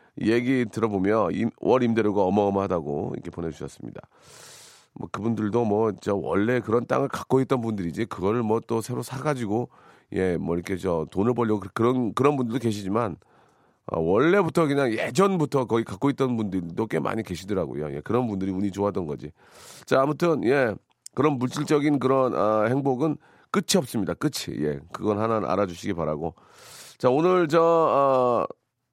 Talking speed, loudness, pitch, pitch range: 350 characters per minute, -25 LUFS, 115 Hz, 100-135 Hz